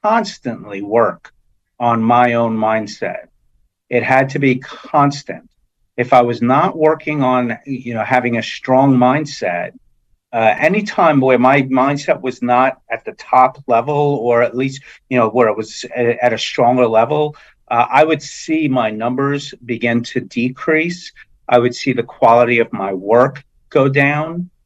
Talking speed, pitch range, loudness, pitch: 160 wpm, 120-145 Hz, -15 LUFS, 125 Hz